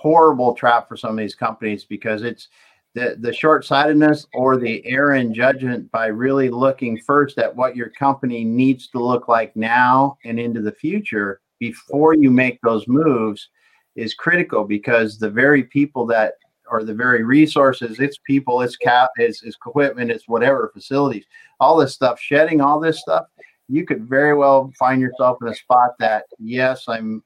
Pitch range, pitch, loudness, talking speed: 115-140 Hz, 125 Hz, -18 LUFS, 170 wpm